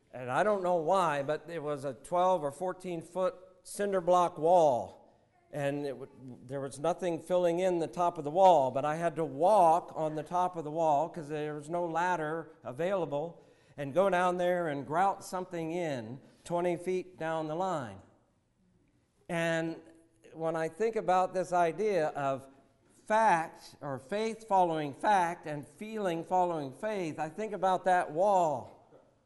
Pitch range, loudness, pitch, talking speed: 150-180 Hz, -31 LUFS, 170 Hz, 165 wpm